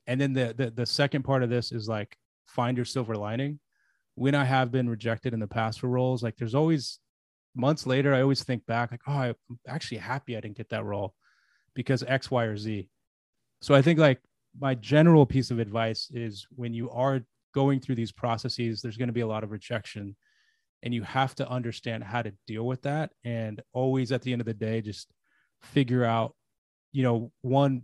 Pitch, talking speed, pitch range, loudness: 120 Hz, 210 wpm, 115-135 Hz, -28 LUFS